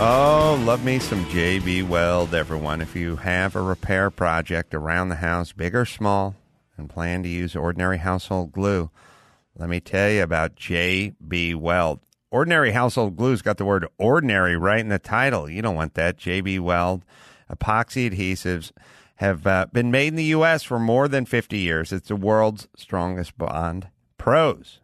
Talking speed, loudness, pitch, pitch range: 170 wpm, -22 LUFS, 95 Hz, 85-110 Hz